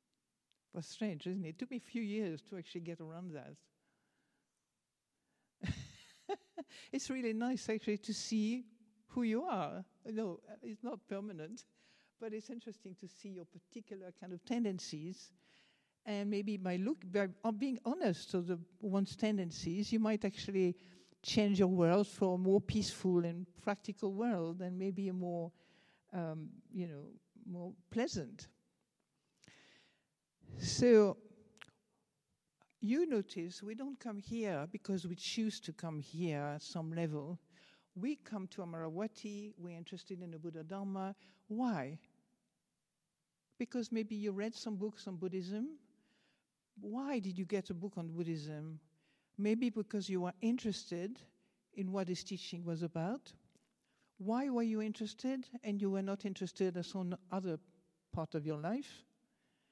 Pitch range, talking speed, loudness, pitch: 175-220 Hz, 145 wpm, -39 LUFS, 195 Hz